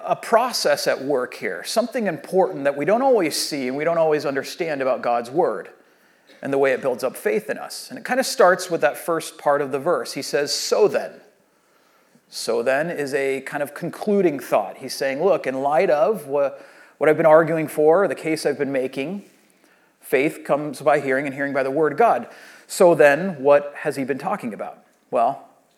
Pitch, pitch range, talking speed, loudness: 155 Hz, 140-195 Hz, 205 wpm, -21 LUFS